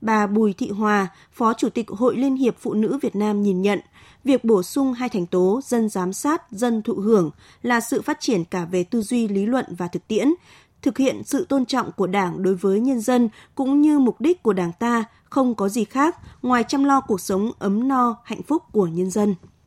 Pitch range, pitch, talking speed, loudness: 200-255 Hz, 225 Hz, 230 wpm, -21 LUFS